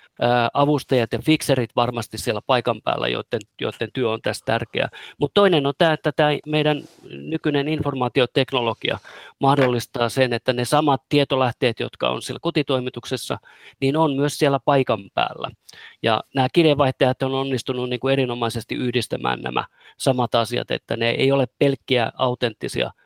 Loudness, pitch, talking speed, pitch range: -21 LUFS, 130 Hz, 145 wpm, 120-145 Hz